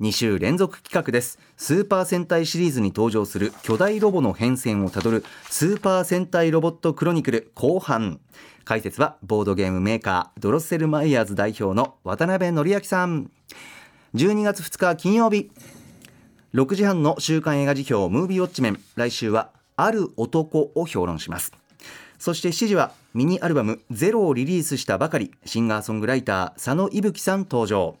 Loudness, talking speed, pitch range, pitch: -22 LUFS, 345 characters per minute, 110-180 Hz, 145 Hz